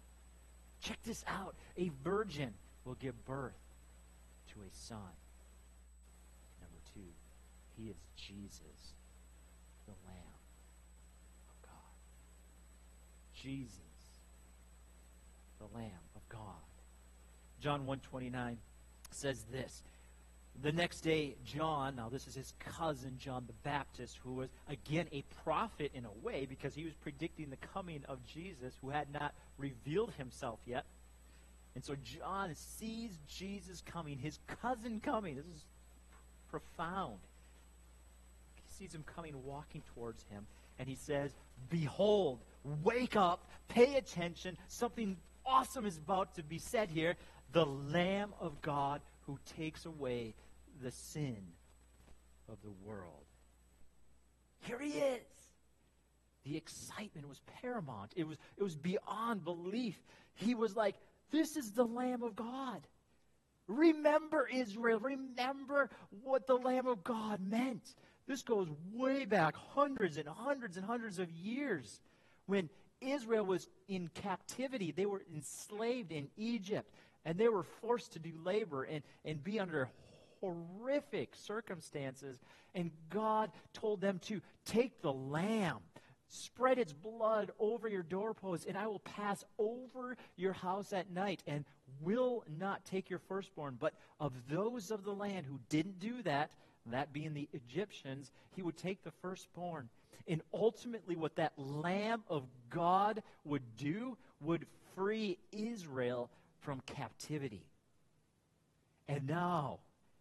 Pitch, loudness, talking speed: 155 Hz, -40 LUFS, 130 wpm